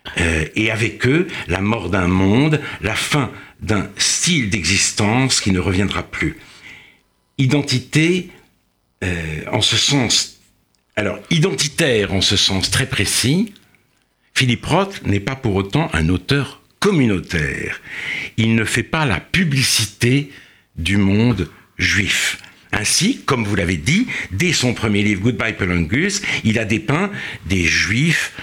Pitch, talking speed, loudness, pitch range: 115 Hz, 130 wpm, -17 LUFS, 95-140 Hz